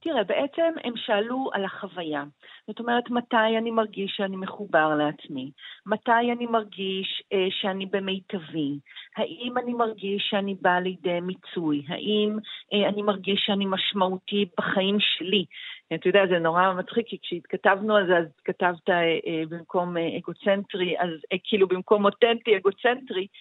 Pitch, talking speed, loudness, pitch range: 195 Hz, 145 wpm, -25 LUFS, 180-215 Hz